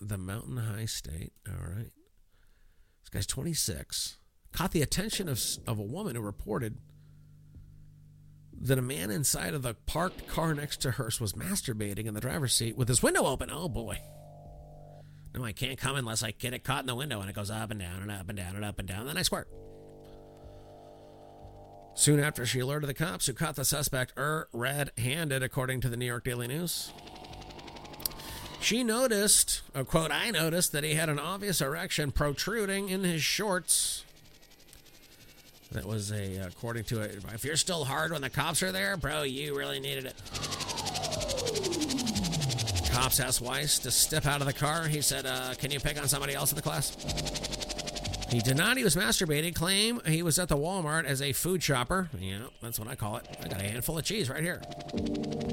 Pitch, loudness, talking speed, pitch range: 135 Hz, -30 LUFS, 190 wpm, 110-155 Hz